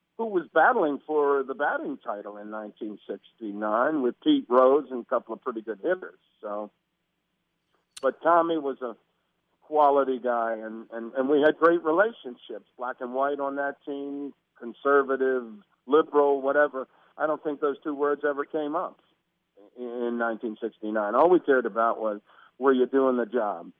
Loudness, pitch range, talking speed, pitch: -26 LUFS, 115-150 Hz, 160 wpm, 135 Hz